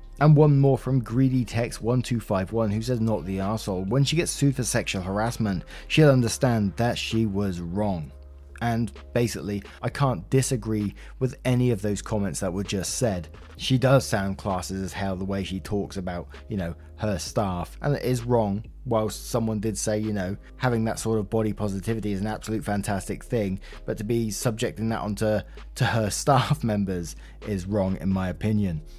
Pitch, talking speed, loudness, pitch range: 110 Hz, 185 wpm, -26 LUFS, 95-120 Hz